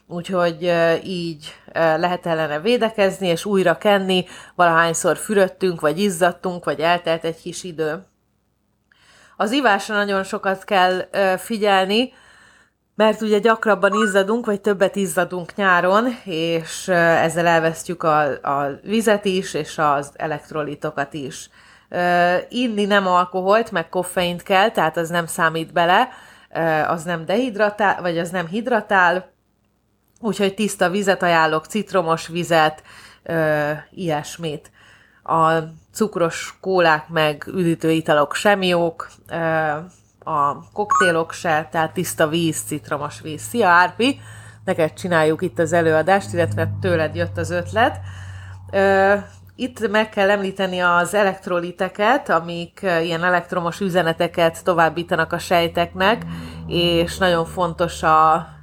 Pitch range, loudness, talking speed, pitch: 160-195 Hz, -19 LUFS, 115 wpm, 175 Hz